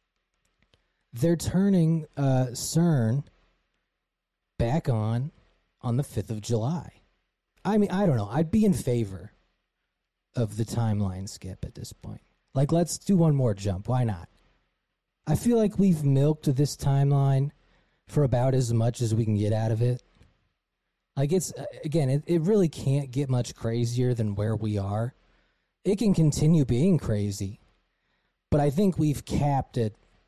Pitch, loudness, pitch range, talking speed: 125 Hz, -26 LUFS, 110-155 Hz, 155 wpm